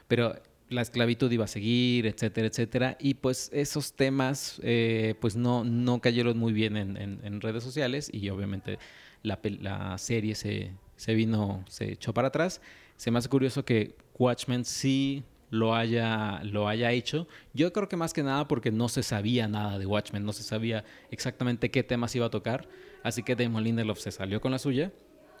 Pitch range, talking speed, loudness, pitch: 110-130 Hz, 185 wpm, -30 LUFS, 115 Hz